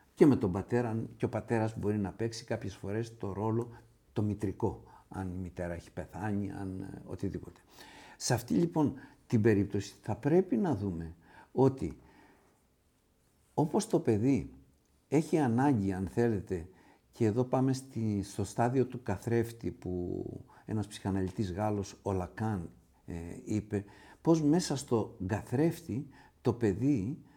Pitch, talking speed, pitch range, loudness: 110 Hz, 135 wpm, 95-125 Hz, -33 LUFS